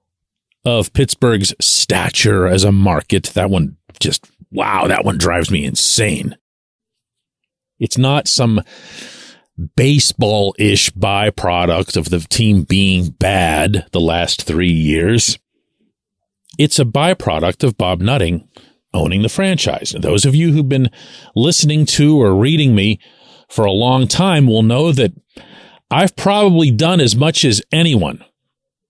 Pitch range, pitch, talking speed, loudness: 95-140 Hz, 110 Hz, 135 wpm, -14 LUFS